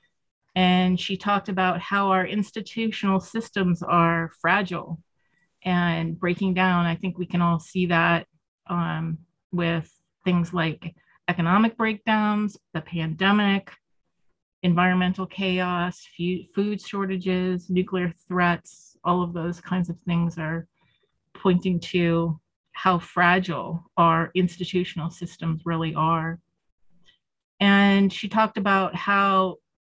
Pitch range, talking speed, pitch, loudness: 170-190 Hz, 110 wpm, 180 Hz, -24 LUFS